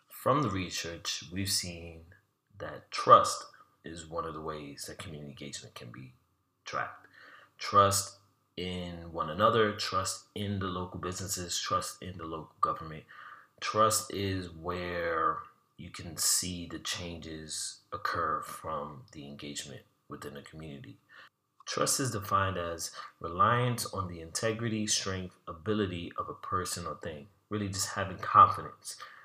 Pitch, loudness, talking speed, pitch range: 90 Hz, -31 LUFS, 135 wpm, 80-100 Hz